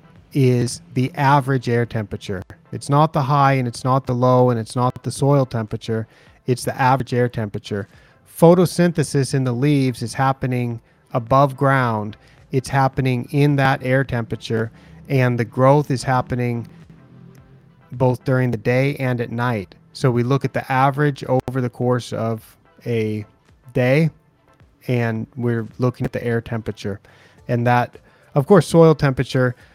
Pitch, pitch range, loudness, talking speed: 130 Hz, 120-135 Hz, -19 LUFS, 155 wpm